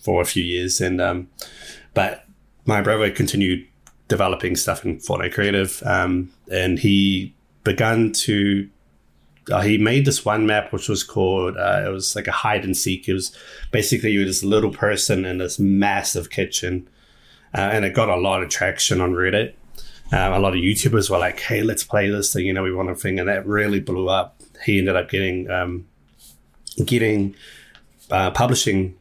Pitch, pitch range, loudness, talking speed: 95 Hz, 90-105 Hz, -20 LUFS, 185 wpm